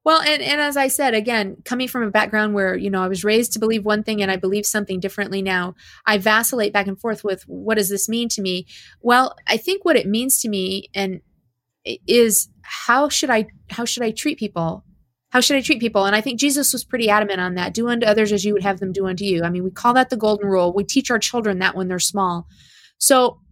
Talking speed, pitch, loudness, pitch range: 255 wpm, 215 Hz, -19 LUFS, 195-240 Hz